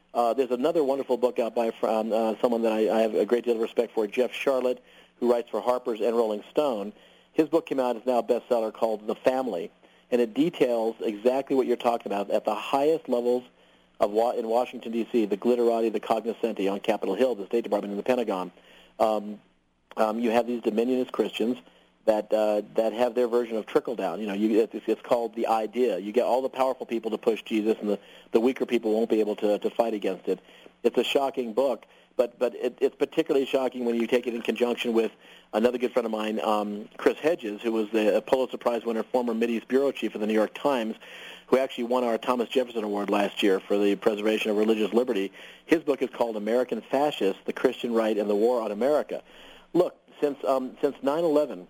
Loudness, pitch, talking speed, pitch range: -26 LUFS, 115 Hz, 220 wpm, 110-125 Hz